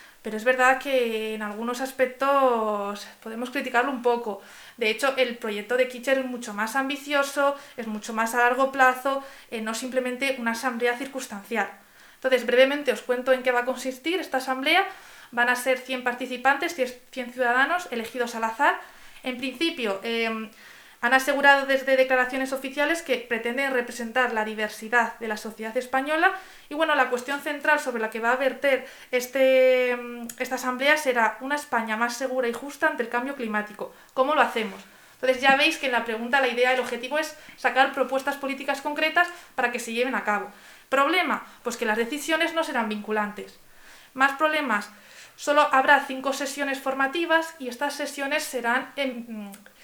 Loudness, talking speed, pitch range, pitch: -24 LUFS, 170 wpm, 235-275 Hz, 255 Hz